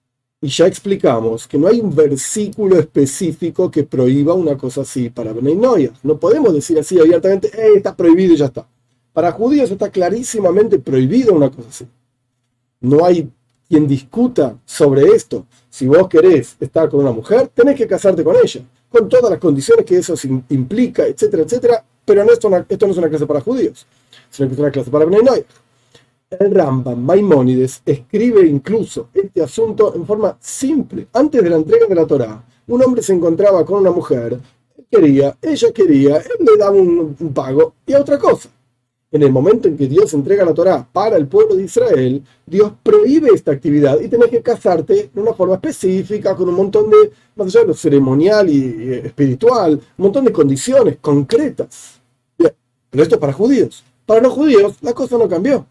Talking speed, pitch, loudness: 185 wpm, 165 Hz, -13 LUFS